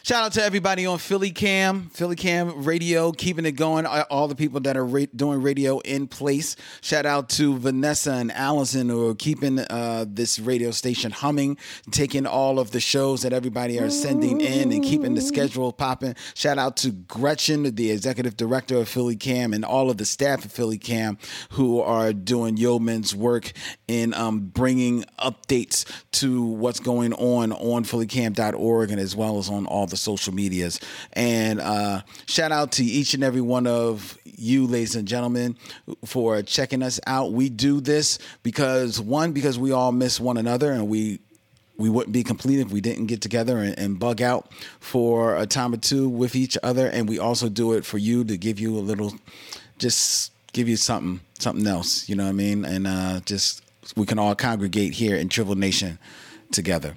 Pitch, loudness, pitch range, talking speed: 120 Hz, -23 LUFS, 110-135 Hz, 190 wpm